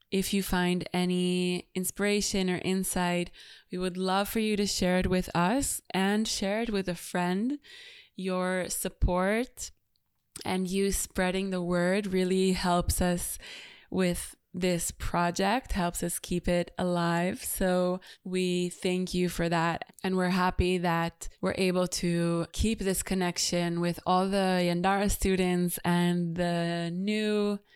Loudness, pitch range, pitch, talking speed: -29 LUFS, 175-195 Hz, 185 Hz, 140 wpm